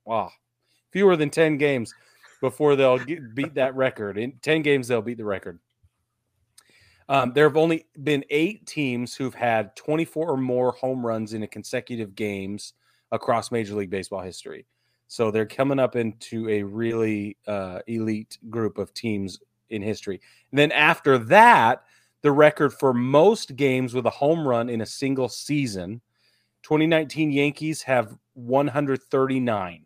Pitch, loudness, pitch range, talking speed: 125 Hz, -23 LUFS, 110-145 Hz, 160 wpm